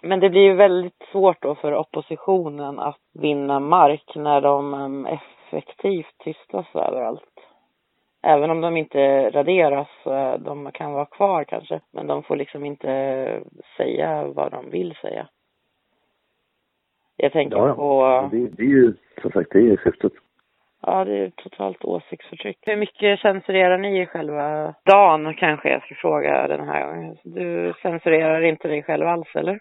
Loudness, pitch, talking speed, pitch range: -20 LUFS, 150 Hz, 150 wpm, 135-180 Hz